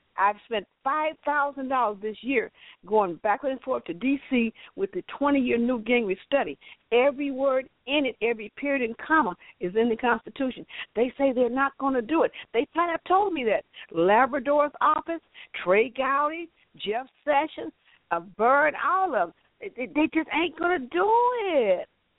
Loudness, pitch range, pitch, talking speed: -26 LUFS, 240-315 Hz, 275 Hz, 170 wpm